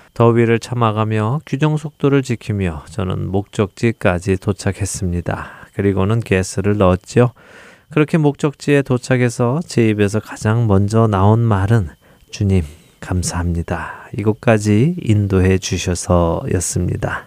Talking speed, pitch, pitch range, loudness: 285 characters per minute, 110 Hz, 95-120 Hz, -17 LUFS